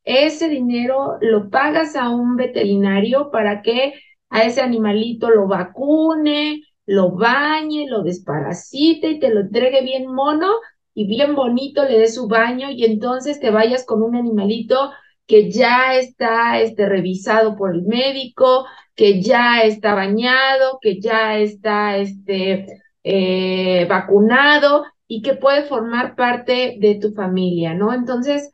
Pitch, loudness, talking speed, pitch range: 235 Hz, -16 LUFS, 140 wpm, 210-270 Hz